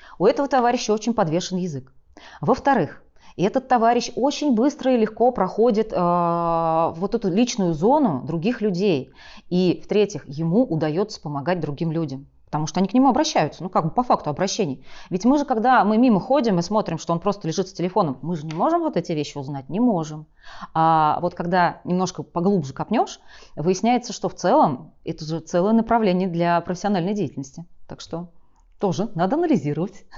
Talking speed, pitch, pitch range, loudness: 175 wpm, 185 Hz, 165-225 Hz, -21 LUFS